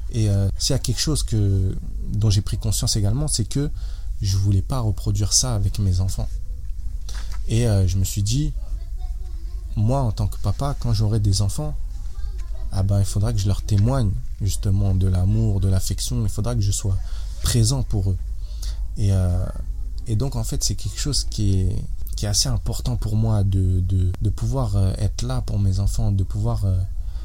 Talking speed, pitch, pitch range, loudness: 190 wpm, 100 Hz, 95-110 Hz, -23 LUFS